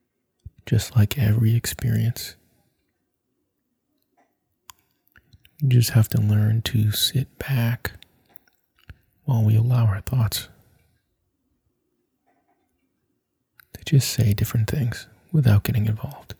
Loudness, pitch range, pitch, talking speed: -22 LUFS, 110-125 Hz, 115 Hz, 90 wpm